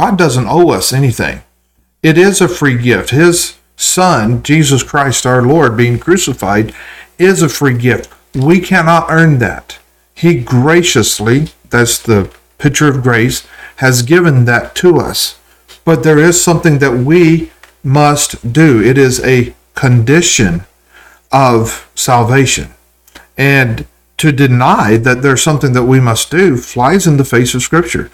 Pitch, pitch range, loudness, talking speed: 135 Hz, 120-160 Hz, -10 LUFS, 145 wpm